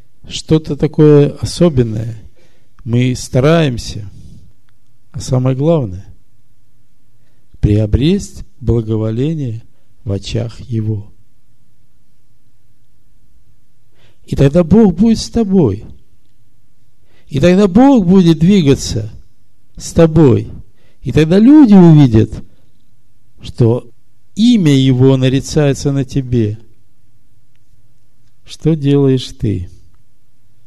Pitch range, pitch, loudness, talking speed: 115-140 Hz, 120 Hz, -12 LUFS, 75 wpm